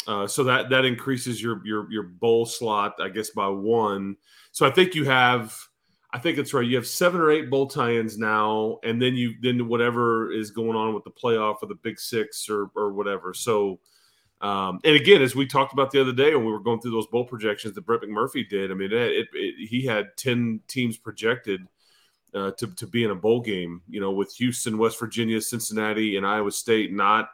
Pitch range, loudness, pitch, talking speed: 105-125 Hz, -24 LUFS, 115 Hz, 220 wpm